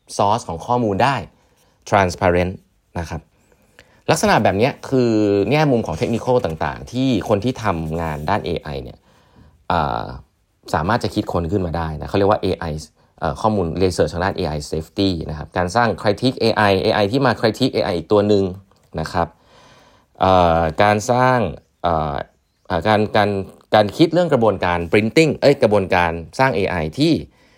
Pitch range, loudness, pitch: 85-110 Hz, -18 LUFS, 100 Hz